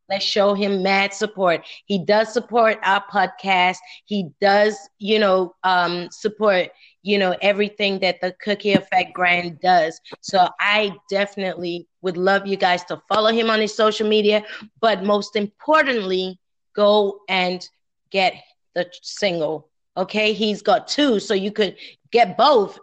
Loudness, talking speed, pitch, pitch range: -20 LUFS, 145 wpm, 200 Hz, 185-215 Hz